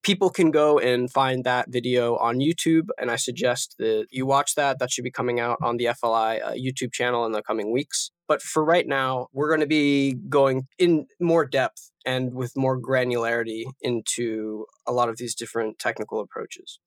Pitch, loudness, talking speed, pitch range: 130 Hz, -24 LUFS, 195 wpm, 120-145 Hz